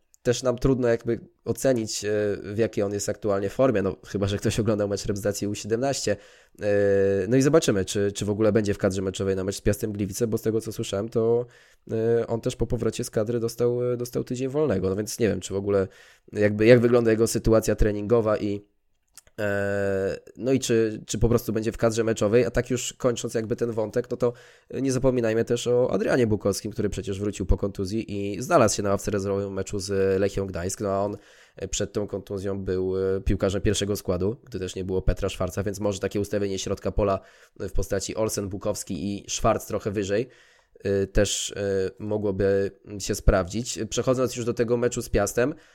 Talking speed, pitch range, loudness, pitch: 190 wpm, 100-115 Hz, -25 LUFS, 105 Hz